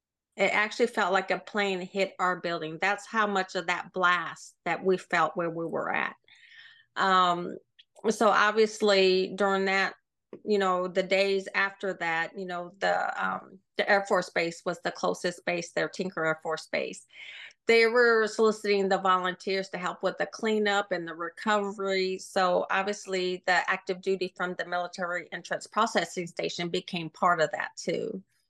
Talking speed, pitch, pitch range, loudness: 165 wpm, 190 Hz, 180-205 Hz, -28 LUFS